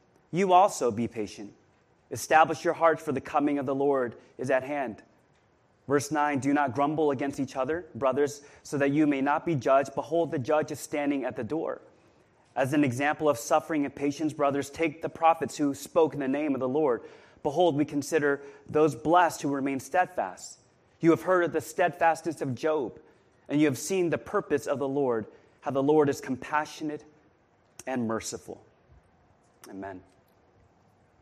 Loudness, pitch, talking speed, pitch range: -27 LUFS, 145 Hz, 175 wpm, 135-160 Hz